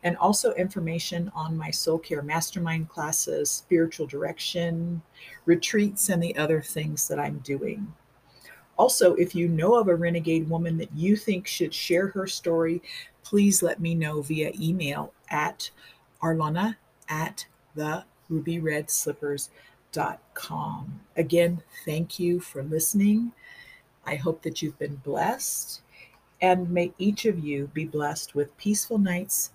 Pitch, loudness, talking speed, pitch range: 165 Hz, -26 LUFS, 140 wpm, 155-180 Hz